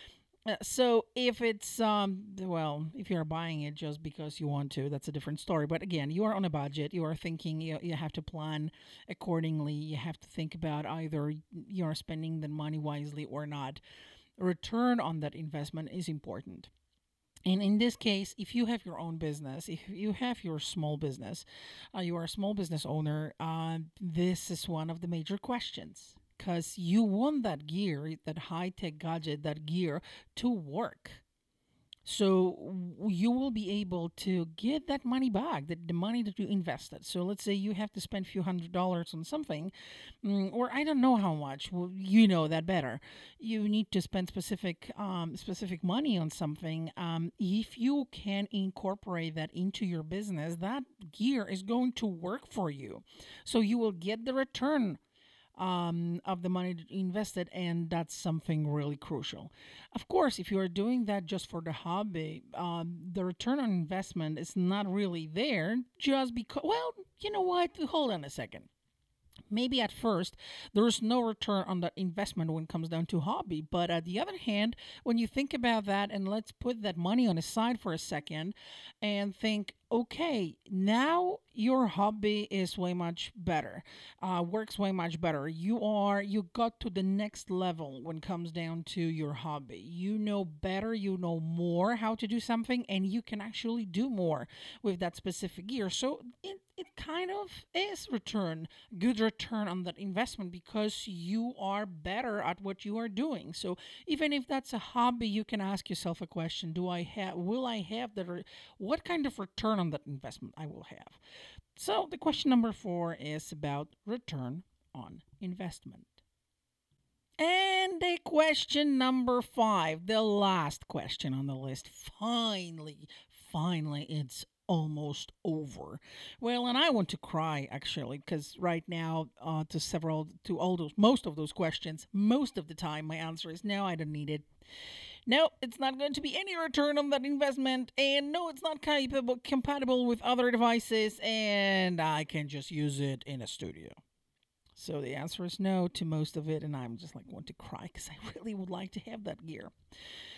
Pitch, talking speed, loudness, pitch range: 185 Hz, 185 wpm, -34 LUFS, 160-225 Hz